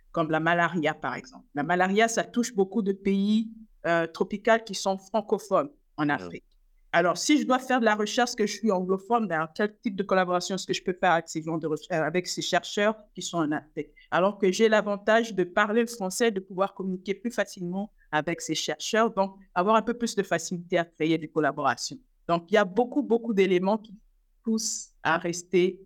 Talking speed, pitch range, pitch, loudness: 205 wpm, 175-220 Hz, 195 Hz, -26 LUFS